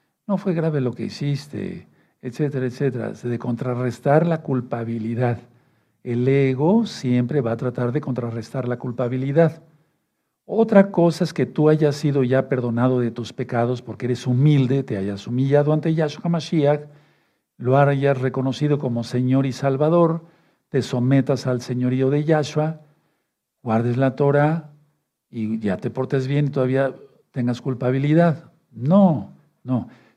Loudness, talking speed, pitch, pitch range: -21 LUFS, 140 wpm, 135 Hz, 125-150 Hz